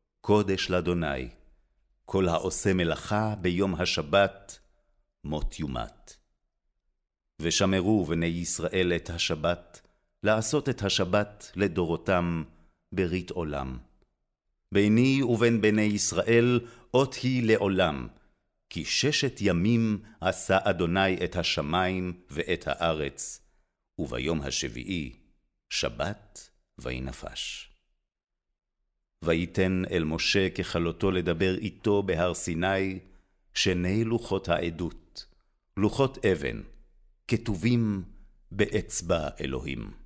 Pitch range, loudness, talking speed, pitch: 85-105 Hz, -27 LUFS, 85 wpm, 95 Hz